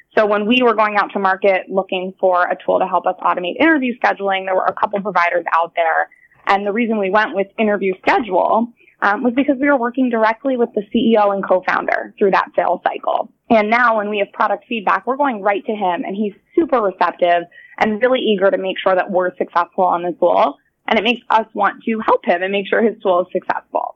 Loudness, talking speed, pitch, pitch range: -17 LUFS, 230 wpm, 205 Hz, 185-235 Hz